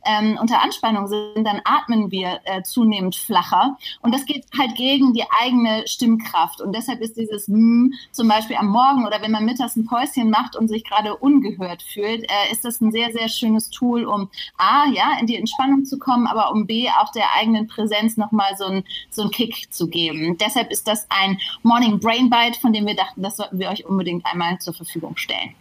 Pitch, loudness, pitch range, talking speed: 220 Hz, -19 LUFS, 205-240 Hz, 210 wpm